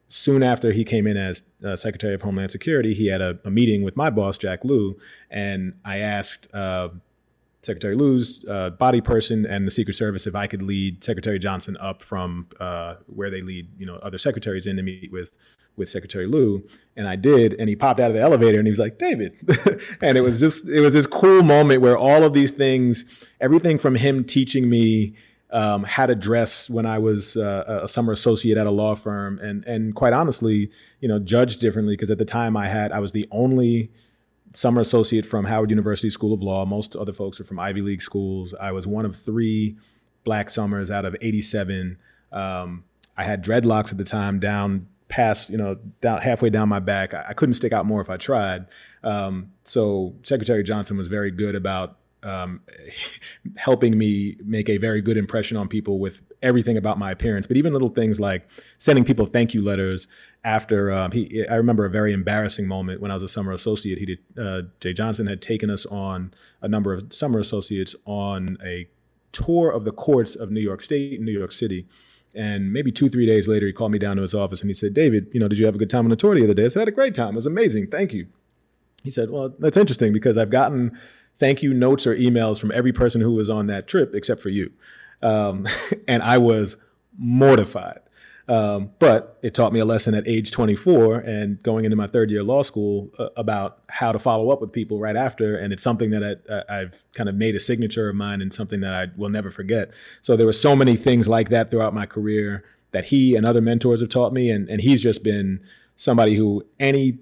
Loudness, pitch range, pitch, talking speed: -21 LUFS, 100-115 Hz, 110 Hz, 225 wpm